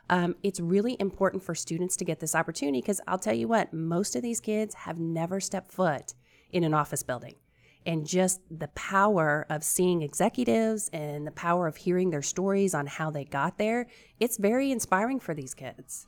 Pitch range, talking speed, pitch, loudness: 155-195 Hz, 195 wpm, 180 Hz, -29 LUFS